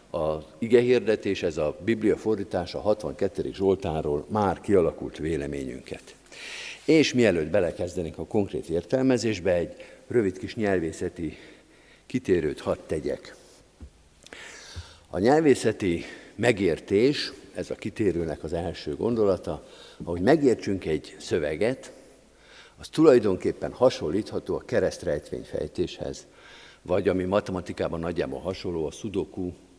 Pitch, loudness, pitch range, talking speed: 95 Hz, -26 LUFS, 85-115 Hz, 105 wpm